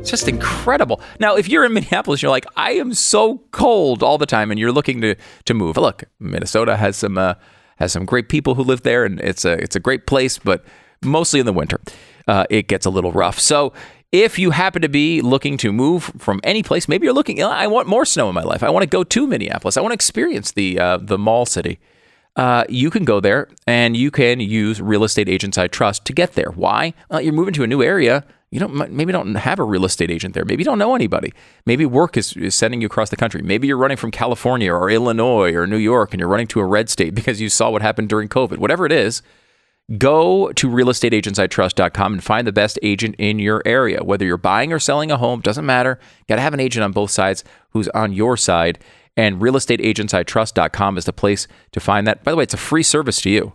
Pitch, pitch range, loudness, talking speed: 110 Hz, 100-135 Hz, -17 LUFS, 240 wpm